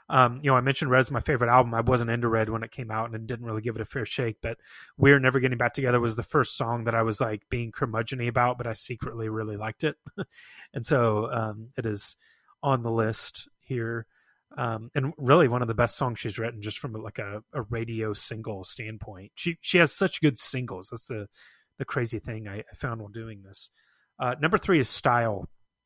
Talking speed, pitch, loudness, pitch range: 225 wpm, 115 Hz, -27 LUFS, 110-130 Hz